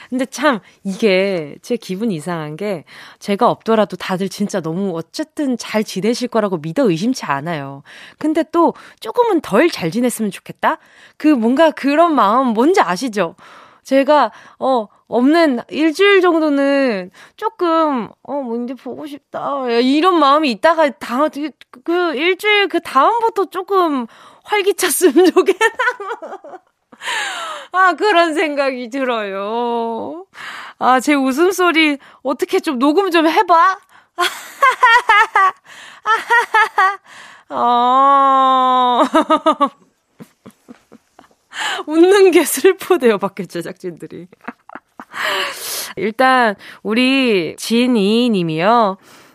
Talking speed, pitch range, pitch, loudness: 200 characters per minute, 230-345 Hz, 275 Hz, -15 LUFS